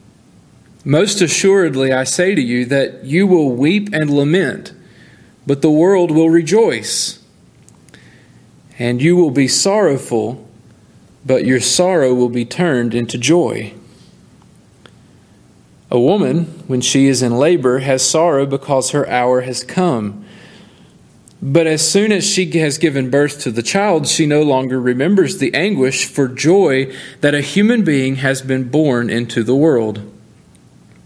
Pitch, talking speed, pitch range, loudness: 140 Hz, 140 wpm, 125-170 Hz, -14 LUFS